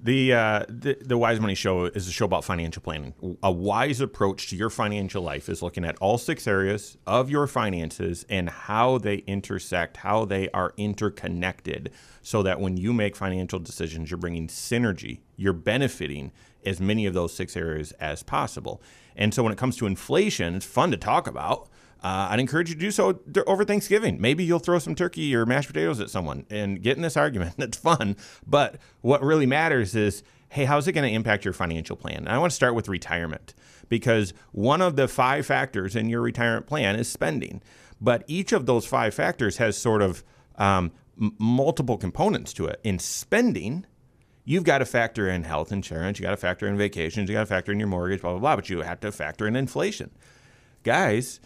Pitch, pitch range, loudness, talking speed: 105 Hz, 95-130 Hz, -25 LUFS, 205 wpm